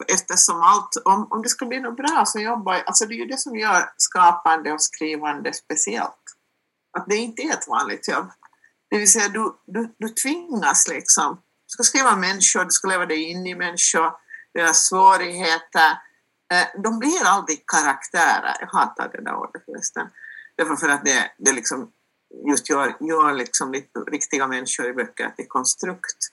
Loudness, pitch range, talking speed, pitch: -20 LUFS, 160-235 Hz, 180 wpm, 190 Hz